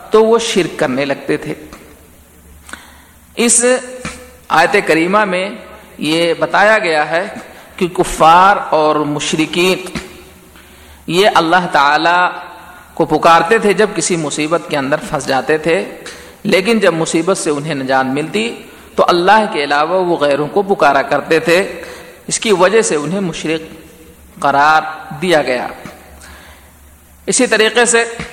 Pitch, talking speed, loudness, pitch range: 165 Hz, 125 wpm, -13 LUFS, 145-195 Hz